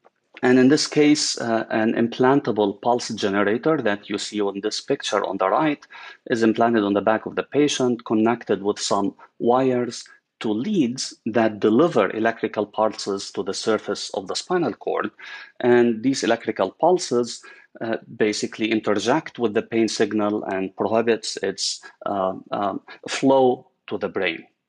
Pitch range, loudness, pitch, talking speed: 105-120 Hz, -22 LUFS, 115 Hz, 155 wpm